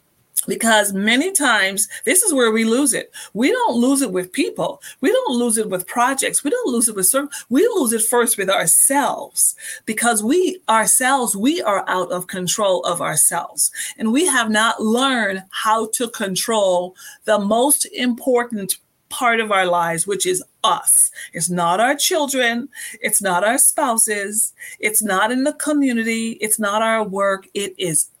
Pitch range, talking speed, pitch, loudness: 200-270 Hz, 170 wpm, 225 Hz, -17 LUFS